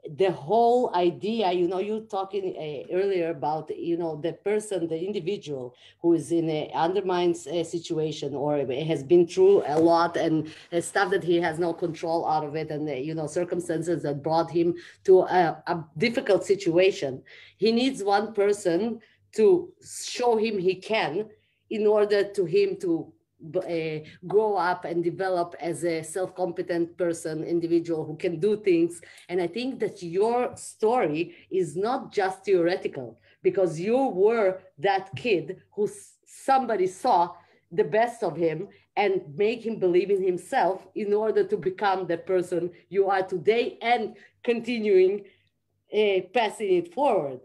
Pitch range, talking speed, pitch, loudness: 170-215 Hz, 155 wpm, 185 Hz, -26 LUFS